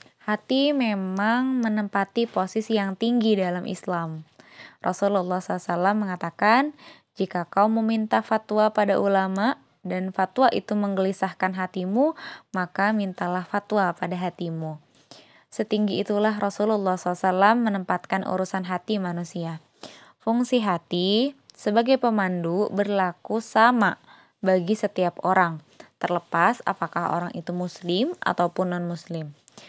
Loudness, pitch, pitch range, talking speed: -24 LUFS, 195 Hz, 180-215 Hz, 105 wpm